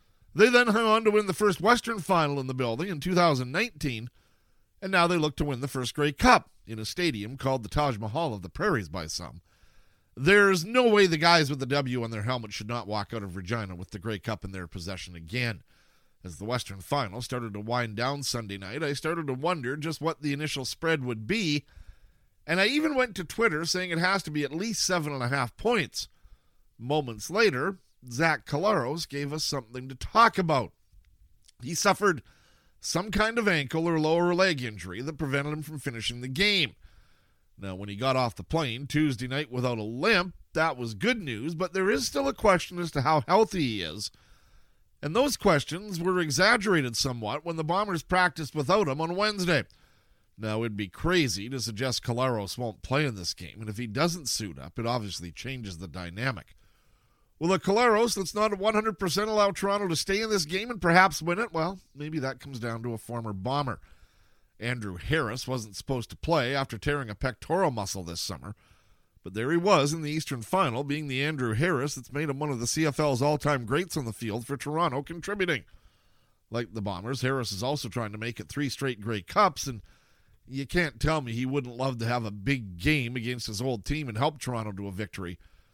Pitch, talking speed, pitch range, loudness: 135 Hz, 205 wpm, 110-165 Hz, -28 LUFS